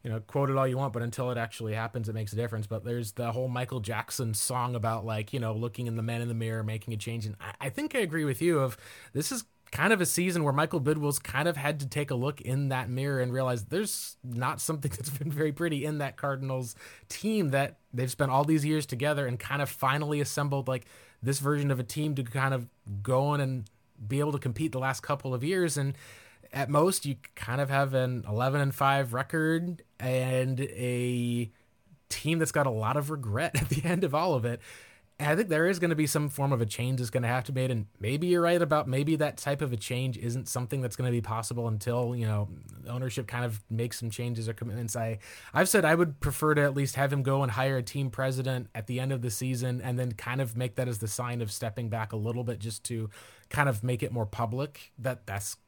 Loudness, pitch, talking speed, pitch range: -30 LUFS, 130 Hz, 255 wpm, 120-145 Hz